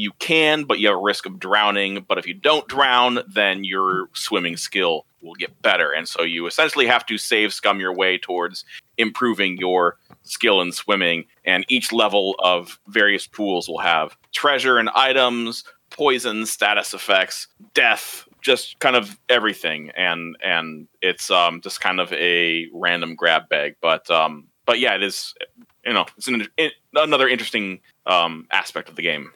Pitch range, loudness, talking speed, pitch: 85-120 Hz, -19 LUFS, 175 wpm, 100 Hz